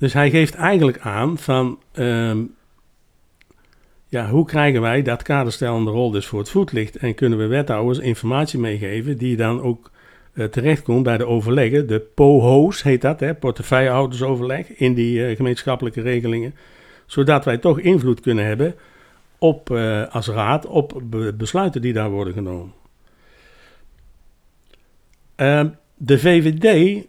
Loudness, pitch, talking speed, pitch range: -18 LUFS, 125 Hz, 135 wpm, 115-145 Hz